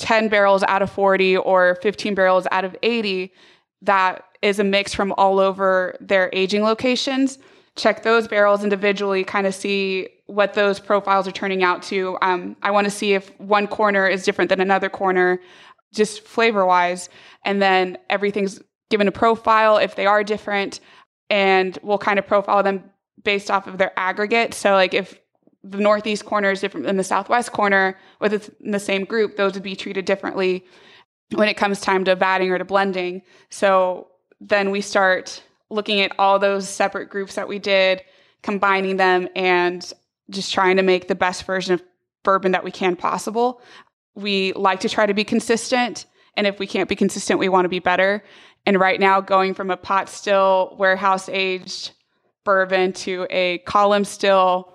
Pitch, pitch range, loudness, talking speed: 195 Hz, 190-205 Hz, -19 LUFS, 185 wpm